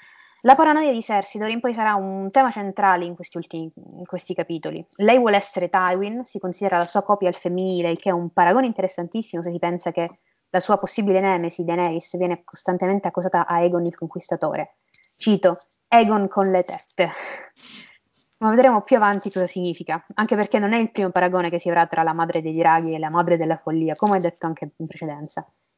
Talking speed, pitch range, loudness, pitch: 200 wpm, 170-205 Hz, -21 LUFS, 180 Hz